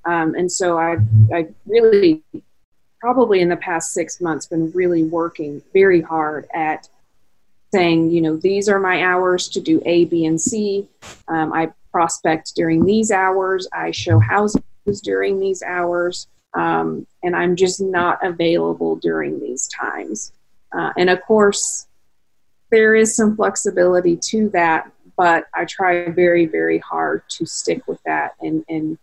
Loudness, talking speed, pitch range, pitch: -18 LUFS, 155 wpm, 160-195 Hz, 175 Hz